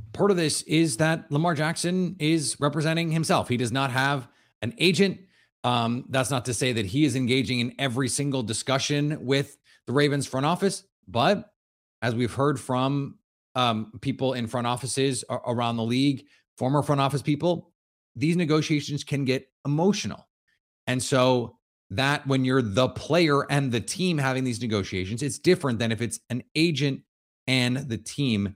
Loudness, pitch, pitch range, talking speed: -25 LUFS, 135 Hz, 125-150 Hz, 165 wpm